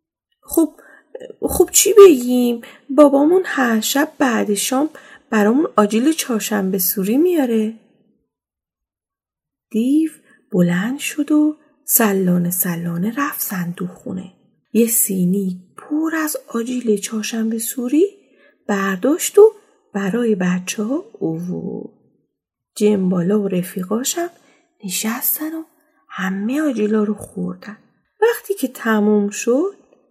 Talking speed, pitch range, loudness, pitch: 100 wpm, 205-300 Hz, -17 LUFS, 235 Hz